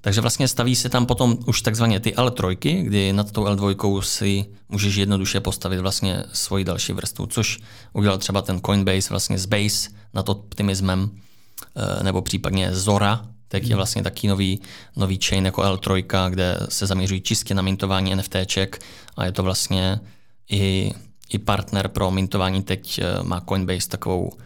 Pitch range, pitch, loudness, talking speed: 95-105 Hz, 100 Hz, -22 LUFS, 155 wpm